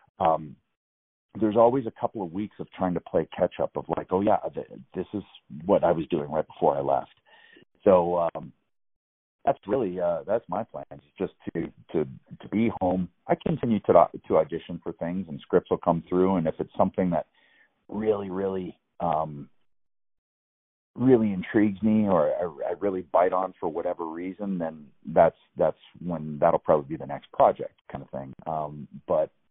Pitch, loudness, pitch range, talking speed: 90 Hz, -26 LUFS, 75-100 Hz, 185 wpm